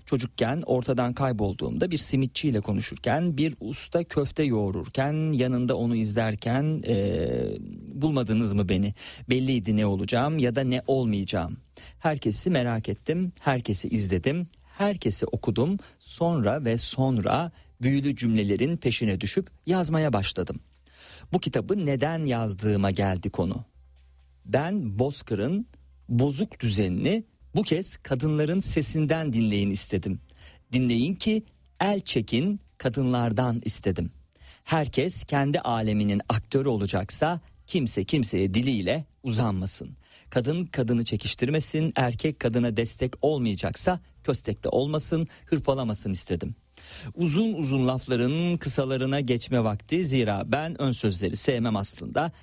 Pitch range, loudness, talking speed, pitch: 105-150 Hz, -26 LUFS, 110 wpm, 125 Hz